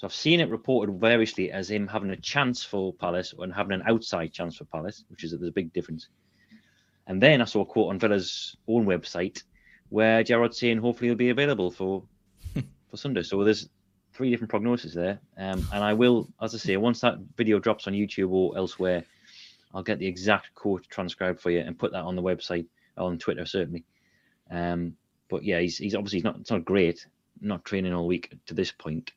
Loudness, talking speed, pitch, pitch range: -27 LUFS, 210 wpm, 100 Hz, 90-115 Hz